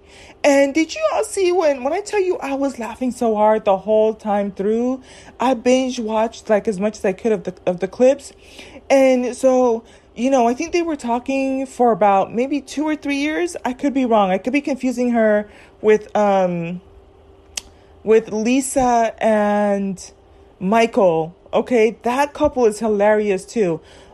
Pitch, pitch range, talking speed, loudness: 230 Hz, 205-265 Hz, 175 wpm, -18 LUFS